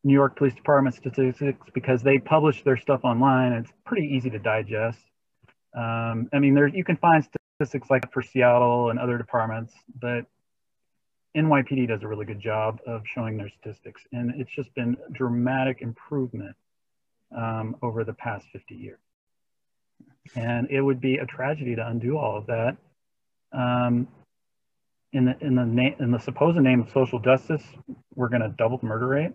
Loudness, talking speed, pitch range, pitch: -24 LUFS, 175 wpm, 115-135 Hz, 125 Hz